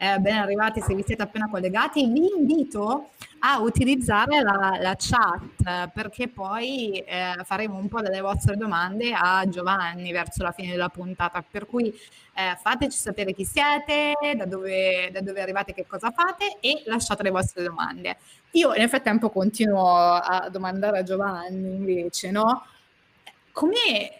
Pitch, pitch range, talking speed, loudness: 200 Hz, 185-235 Hz, 155 wpm, -24 LUFS